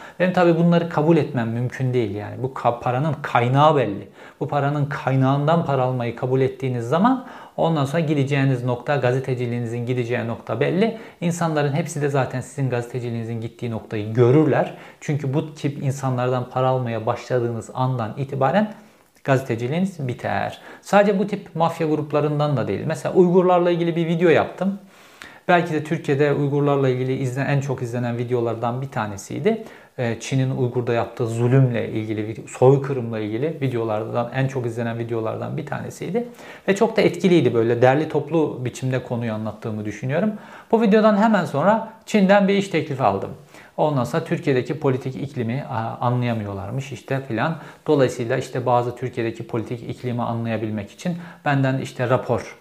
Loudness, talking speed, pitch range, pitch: -21 LUFS, 145 wpm, 120-160 Hz, 130 Hz